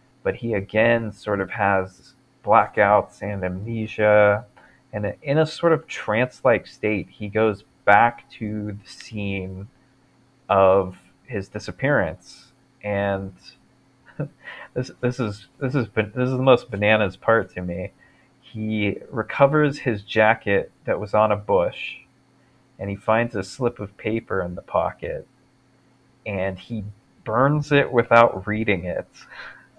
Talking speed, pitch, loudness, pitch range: 130 wpm, 110 Hz, -22 LUFS, 100-130 Hz